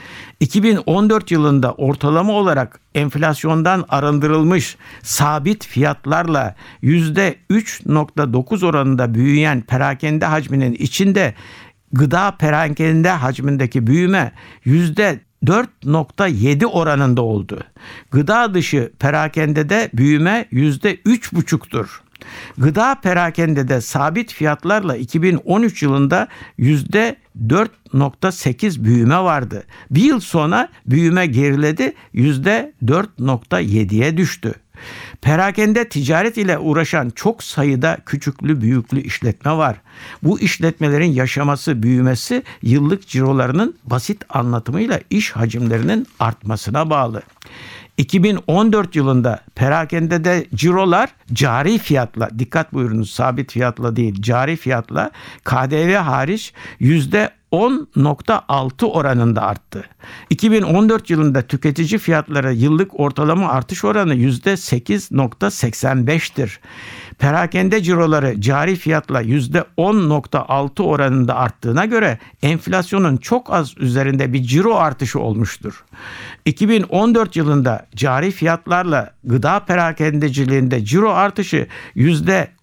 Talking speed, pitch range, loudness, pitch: 85 wpm, 130-180 Hz, -16 LUFS, 150 Hz